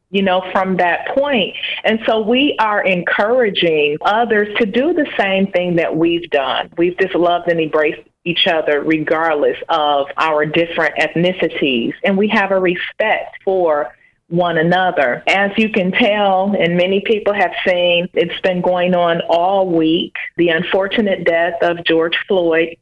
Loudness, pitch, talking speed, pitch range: -15 LUFS, 180 Hz, 160 wpm, 165-195 Hz